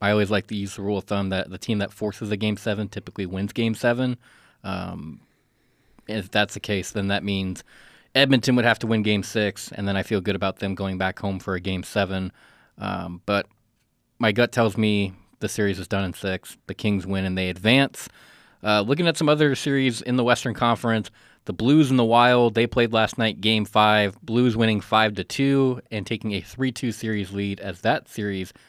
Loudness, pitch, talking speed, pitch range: -23 LUFS, 105 Hz, 220 wpm, 100-115 Hz